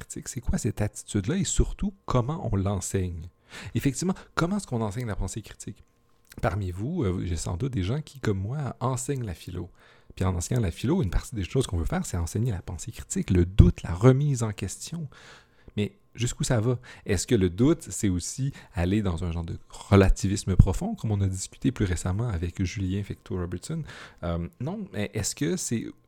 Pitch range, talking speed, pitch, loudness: 95-125 Hz, 200 wpm, 105 Hz, -28 LUFS